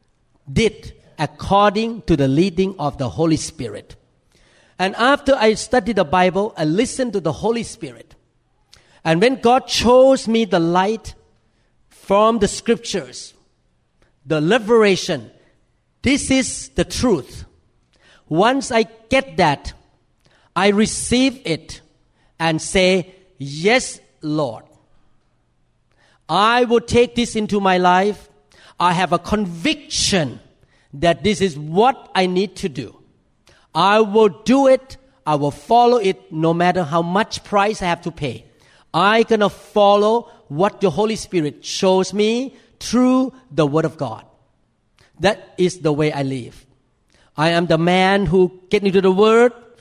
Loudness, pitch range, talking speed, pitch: -17 LUFS, 160-225 Hz, 135 wpm, 190 Hz